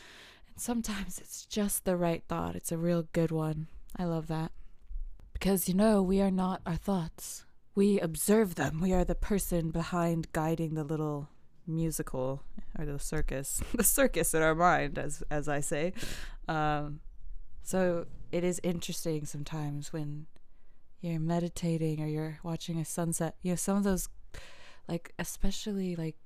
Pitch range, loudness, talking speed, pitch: 155-185 Hz, -32 LUFS, 155 wpm, 165 Hz